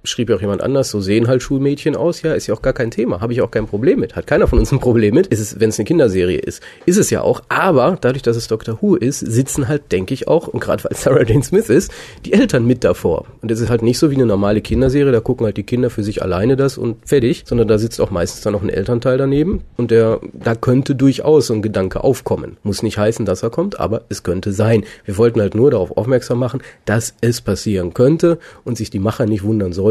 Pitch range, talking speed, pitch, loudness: 110-130 Hz, 265 wpm, 115 Hz, -16 LUFS